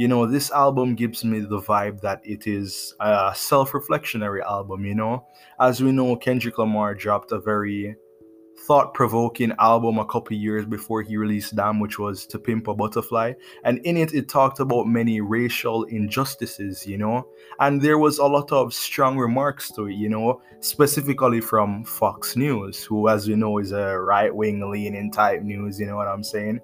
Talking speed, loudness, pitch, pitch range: 180 wpm, -22 LUFS, 110 Hz, 105-125 Hz